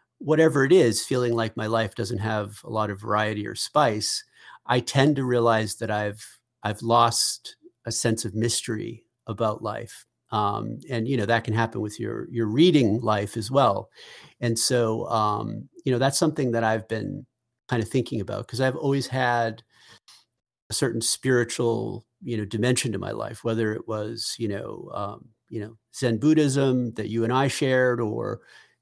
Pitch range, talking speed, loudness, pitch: 110-125 Hz, 180 wpm, -24 LUFS, 115 Hz